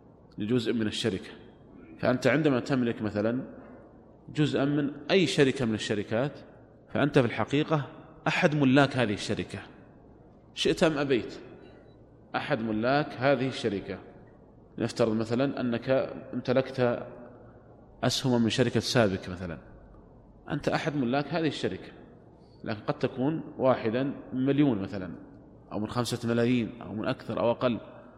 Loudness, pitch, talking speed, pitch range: -28 LUFS, 125 Hz, 125 wpm, 110-140 Hz